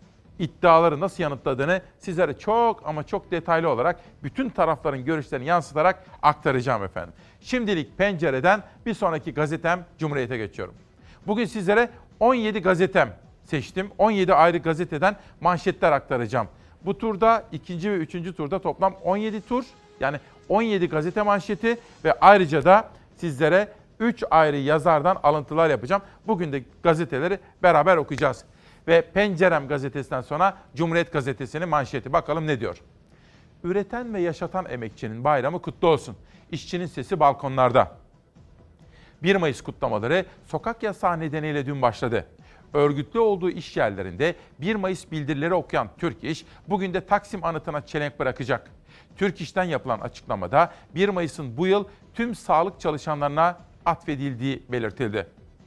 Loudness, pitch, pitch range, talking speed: -24 LUFS, 170 Hz, 150-195 Hz, 125 wpm